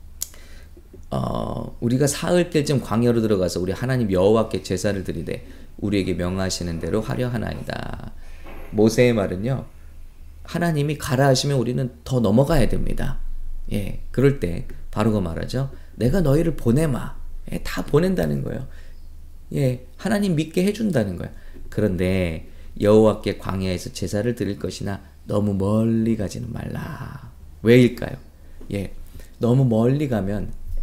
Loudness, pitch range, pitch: -22 LUFS, 80-125 Hz, 100 Hz